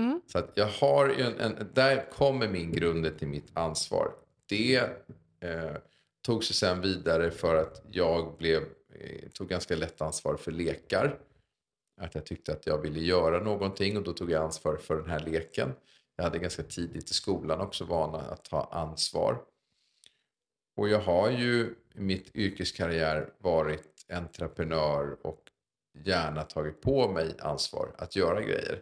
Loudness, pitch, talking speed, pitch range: -30 LUFS, 85 Hz, 160 wpm, 80-105 Hz